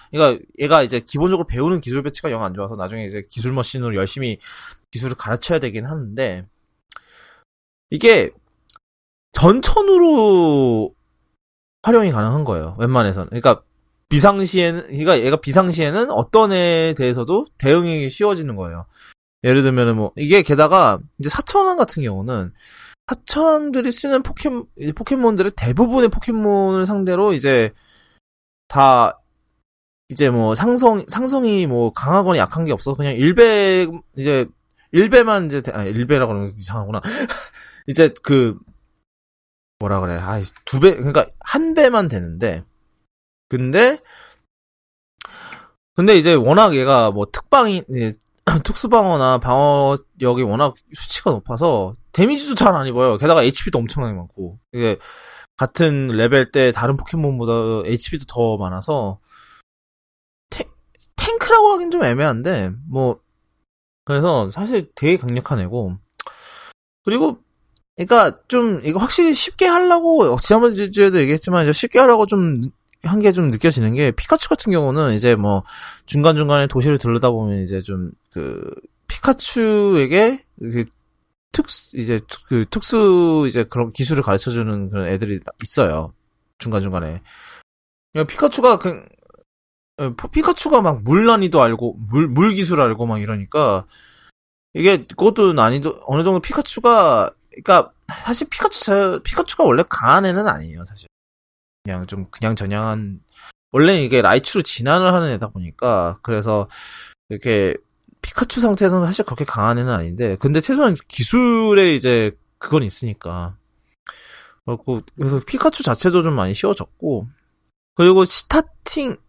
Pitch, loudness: 140 Hz, -16 LUFS